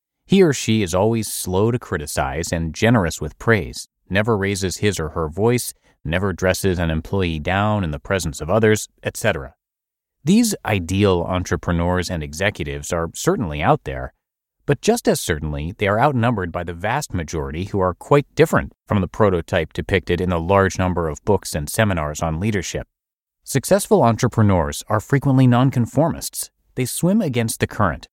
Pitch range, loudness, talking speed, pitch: 85-115 Hz, -20 LUFS, 165 wpm, 95 Hz